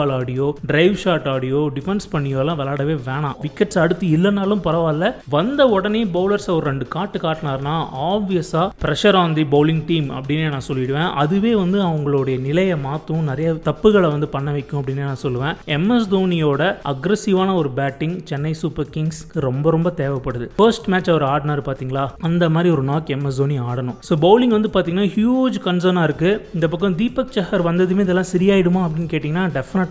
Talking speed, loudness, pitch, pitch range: 165 wpm, -19 LUFS, 160 Hz, 145-185 Hz